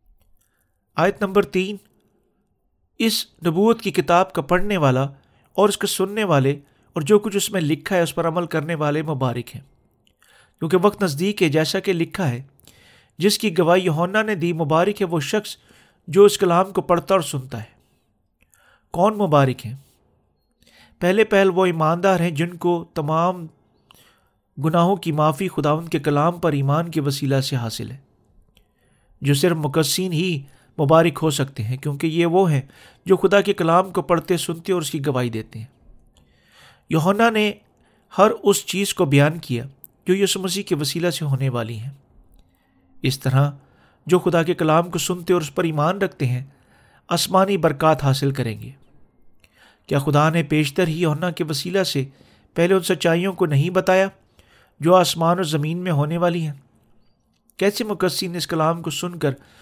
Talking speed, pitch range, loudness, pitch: 170 wpm, 140-185 Hz, -20 LUFS, 165 Hz